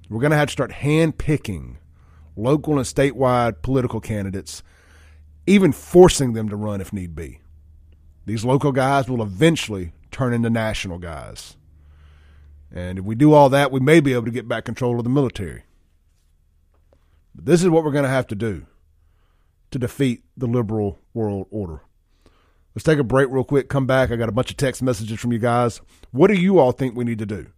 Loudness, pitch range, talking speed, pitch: -19 LUFS, 80-130 Hz, 195 wpm, 110 Hz